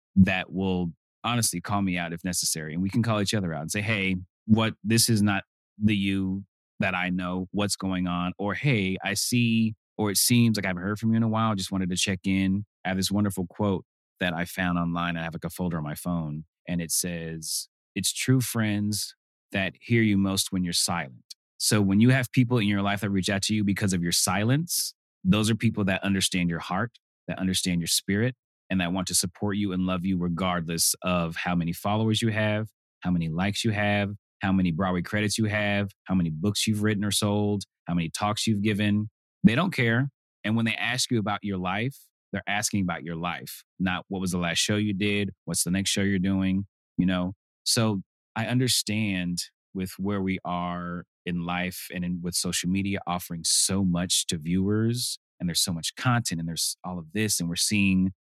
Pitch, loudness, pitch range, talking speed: 95 Hz, -26 LUFS, 90-105 Hz, 220 wpm